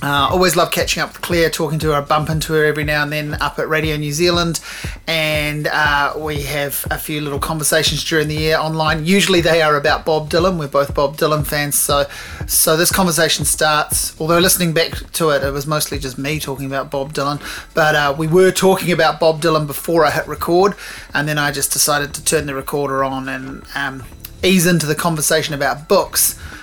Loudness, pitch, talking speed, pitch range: -16 LUFS, 155 Hz, 215 wpm, 145-165 Hz